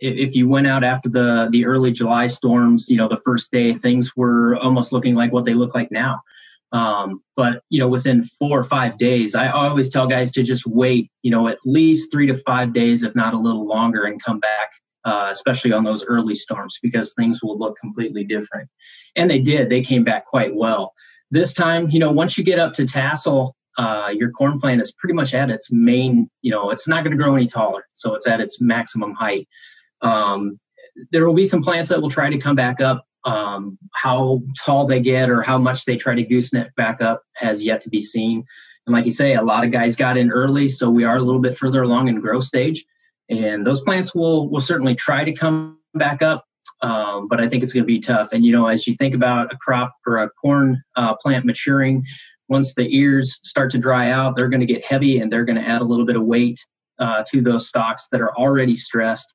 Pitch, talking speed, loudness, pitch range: 125 Hz, 235 wpm, -18 LUFS, 115-135 Hz